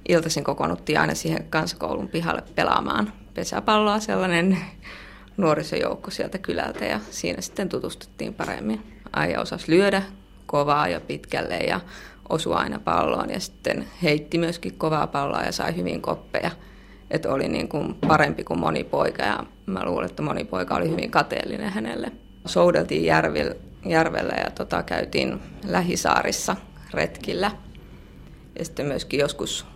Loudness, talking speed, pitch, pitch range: -24 LUFS, 135 wpm, 170 Hz, 145-185 Hz